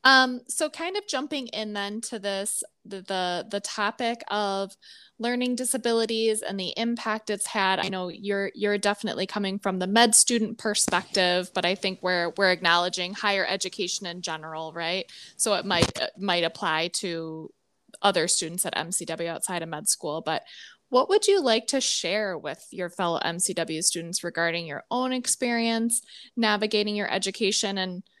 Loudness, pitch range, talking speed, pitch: -26 LUFS, 180-230 Hz, 165 wpm, 200 Hz